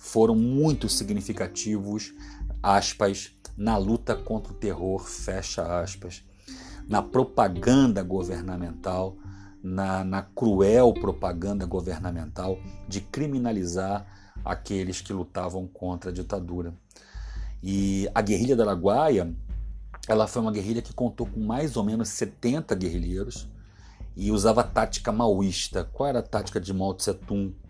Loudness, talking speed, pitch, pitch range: -27 LUFS, 120 wpm, 100 Hz, 90-110 Hz